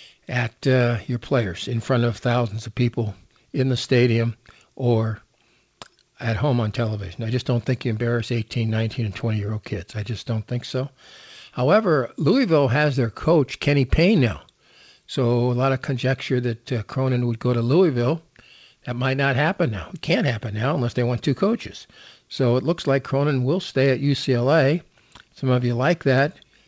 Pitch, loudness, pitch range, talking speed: 125 Hz, -22 LUFS, 115-135 Hz, 185 wpm